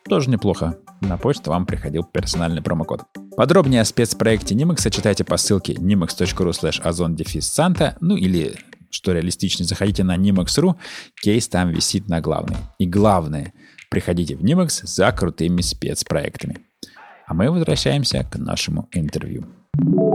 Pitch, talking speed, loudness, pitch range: 95 Hz, 130 wpm, -20 LUFS, 85-115 Hz